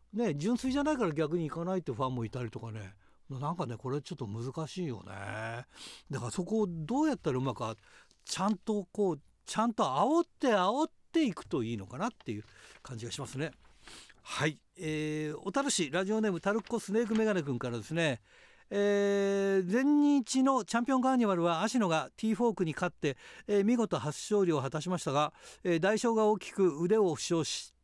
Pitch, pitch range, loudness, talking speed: 180 Hz, 140-220 Hz, -32 LUFS, 380 characters per minute